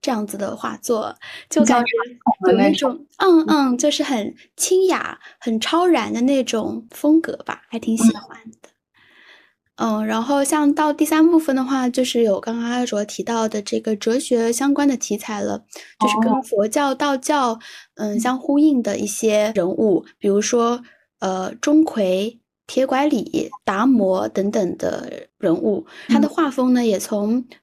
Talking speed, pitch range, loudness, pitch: 225 characters per minute, 220-290 Hz, -19 LUFS, 245 Hz